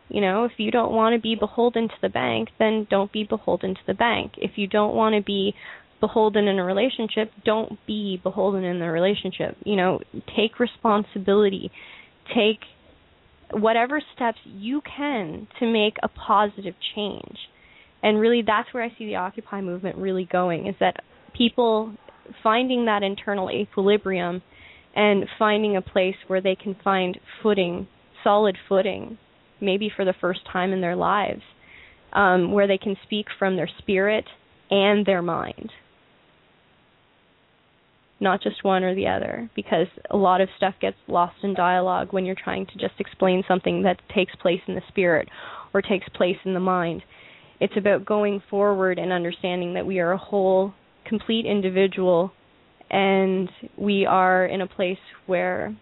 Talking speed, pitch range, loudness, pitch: 160 wpm, 185-215 Hz, -23 LUFS, 195 Hz